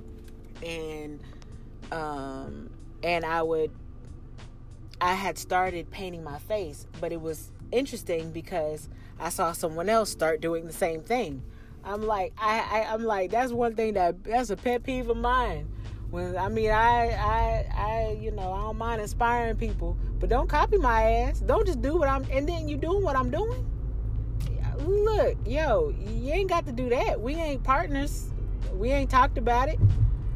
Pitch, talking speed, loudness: 165 Hz, 170 wpm, -28 LUFS